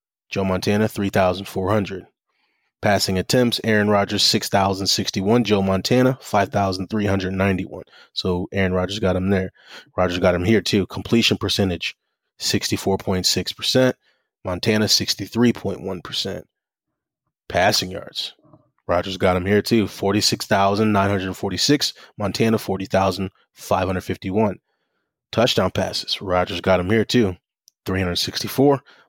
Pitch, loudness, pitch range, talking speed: 100 Hz, -20 LUFS, 95-110 Hz, 95 wpm